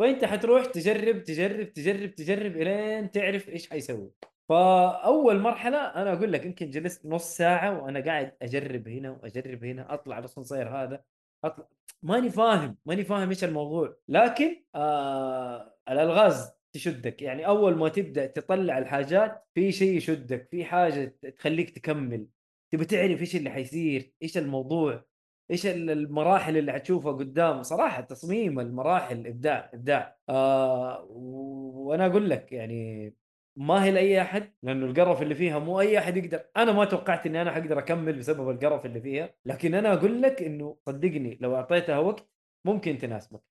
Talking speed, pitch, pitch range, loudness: 150 wpm, 160 Hz, 135-190 Hz, -27 LUFS